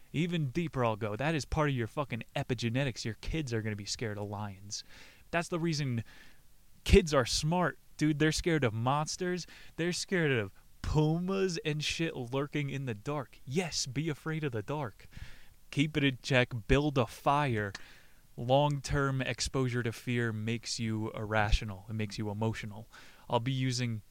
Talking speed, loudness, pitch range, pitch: 170 wpm, -33 LUFS, 115-150 Hz, 130 Hz